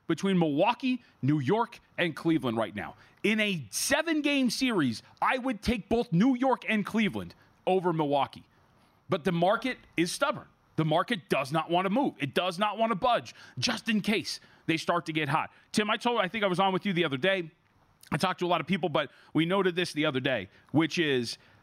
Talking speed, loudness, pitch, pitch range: 215 wpm, -29 LUFS, 185 Hz, 155-220 Hz